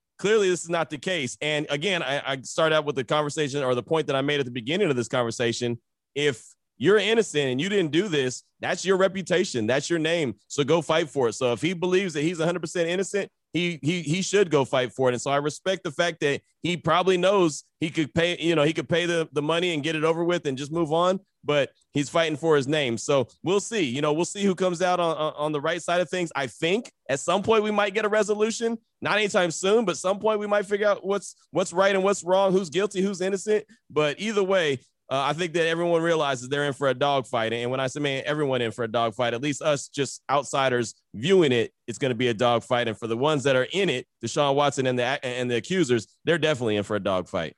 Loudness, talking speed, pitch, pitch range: -25 LUFS, 255 wpm, 160 Hz, 135-185 Hz